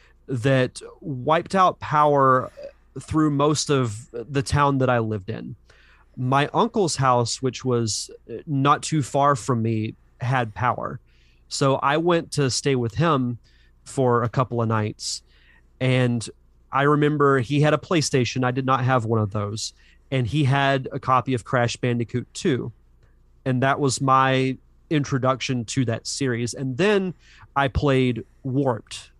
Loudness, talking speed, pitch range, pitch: -22 LUFS, 150 wpm, 115-140 Hz, 130 Hz